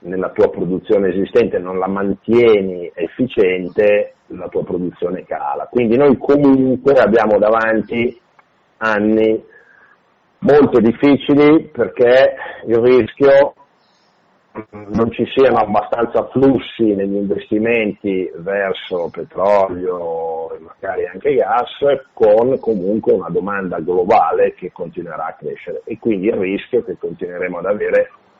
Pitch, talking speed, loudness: 125 Hz, 115 wpm, -15 LUFS